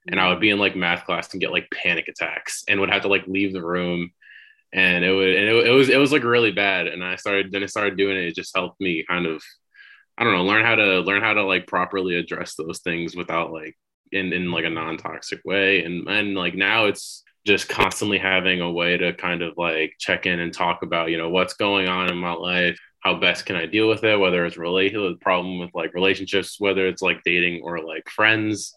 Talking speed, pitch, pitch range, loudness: 245 wpm, 95 Hz, 85-100 Hz, -21 LUFS